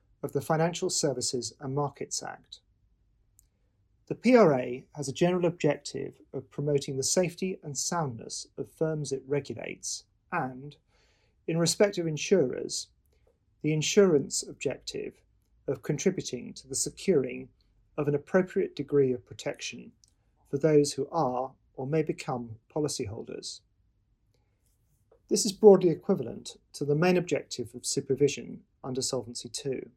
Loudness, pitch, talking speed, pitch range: -29 LUFS, 140 Hz, 125 wpm, 115-160 Hz